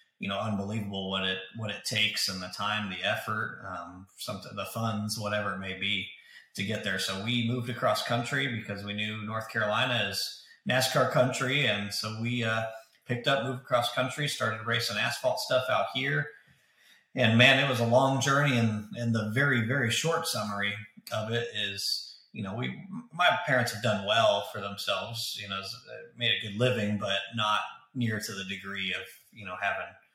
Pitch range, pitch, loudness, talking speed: 100-125 Hz, 110 Hz, -29 LUFS, 190 wpm